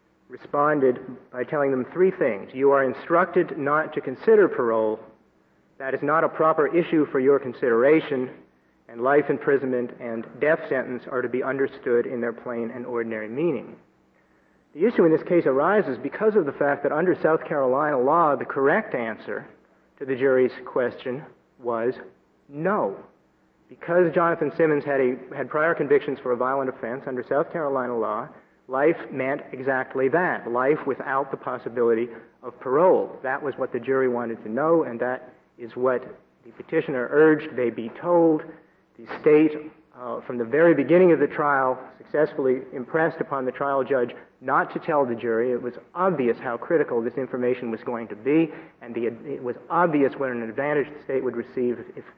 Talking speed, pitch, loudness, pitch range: 175 wpm, 130 Hz, -23 LUFS, 120-150 Hz